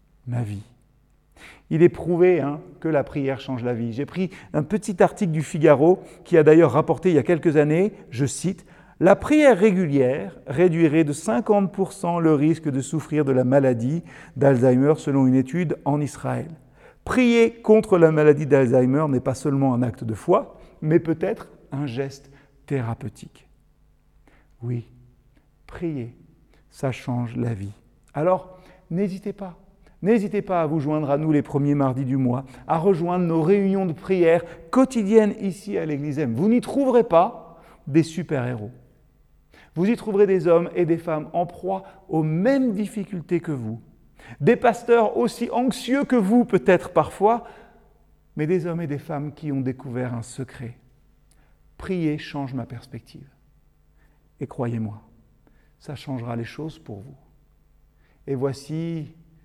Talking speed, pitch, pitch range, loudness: 155 wpm, 155 Hz, 135-185 Hz, -21 LUFS